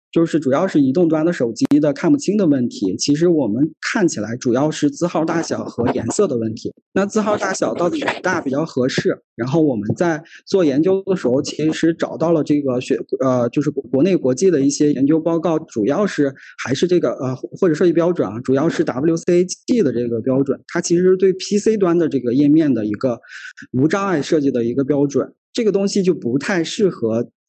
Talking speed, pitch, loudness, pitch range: 315 characters per minute, 160 Hz, -18 LUFS, 135-185 Hz